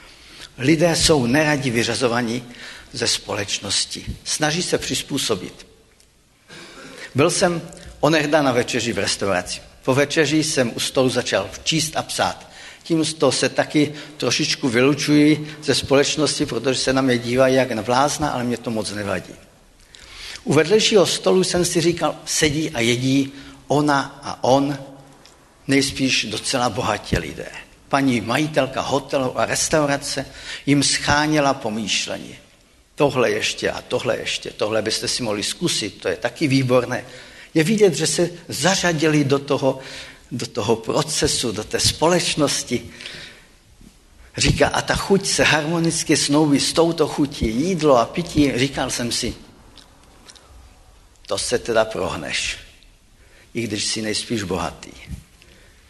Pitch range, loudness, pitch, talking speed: 120-155 Hz, -20 LUFS, 140 Hz, 130 wpm